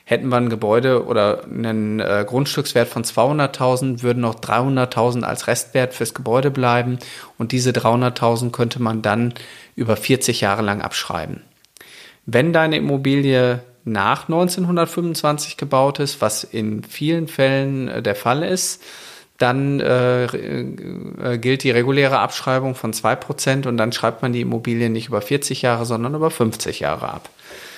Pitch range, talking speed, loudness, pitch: 115-135 Hz, 140 wpm, -19 LUFS, 125 Hz